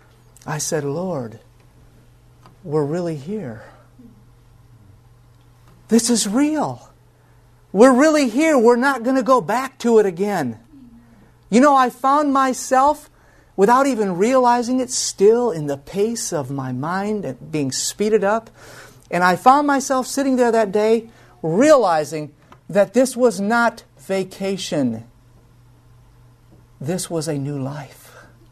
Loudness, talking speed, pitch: -18 LUFS, 125 wpm, 185 Hz